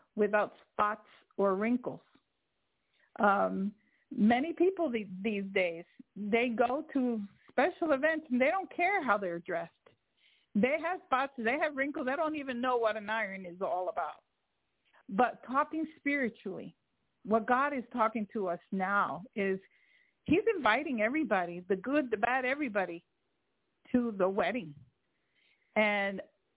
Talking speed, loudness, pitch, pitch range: 140 wpm, -32 LUFS, 235 Hz, 200-280 Hz